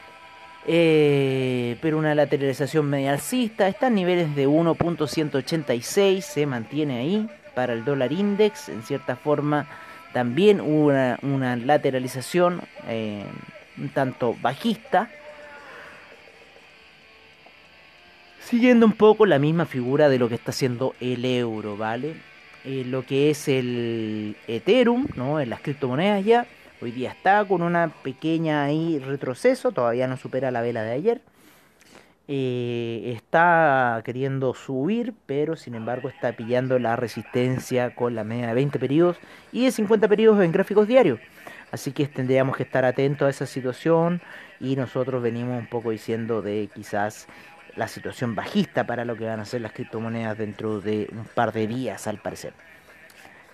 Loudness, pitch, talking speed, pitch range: -23 LUFS, 135 Hz, 145 wpm, 120-165 Hz